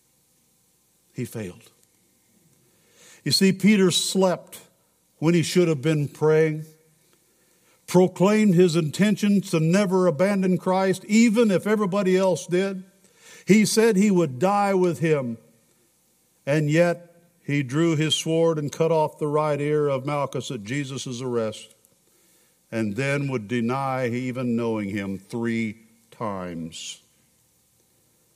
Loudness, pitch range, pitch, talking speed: -22 LUFS, 125-185 Hz, 160 Hz, 120 wpm